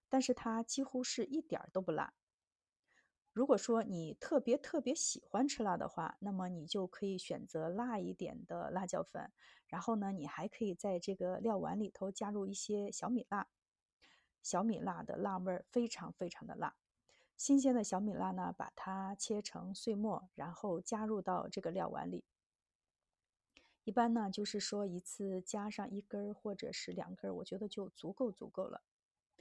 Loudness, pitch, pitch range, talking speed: -40 LUFS, 205 Hz, 190-230 Hz, 255 characters per minute